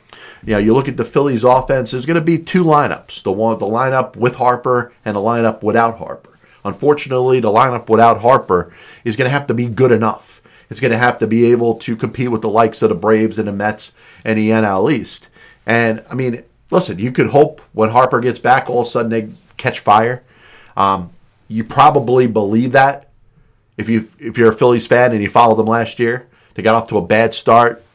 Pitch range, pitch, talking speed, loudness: 110-125 Hz, 115 Hz, 225 wpm, -14 LUFS